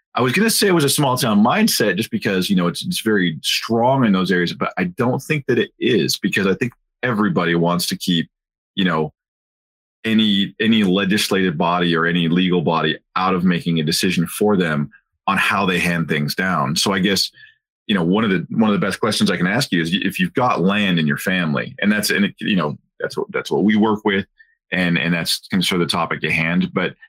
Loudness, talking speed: -18 LUFS, 240 wpm